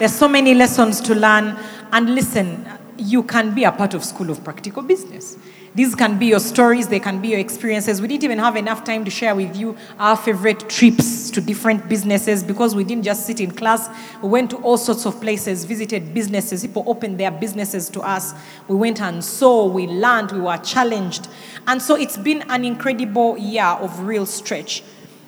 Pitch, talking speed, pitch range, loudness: 215 Hz, 200 wpm, 200-235 Hz, -18 LUFS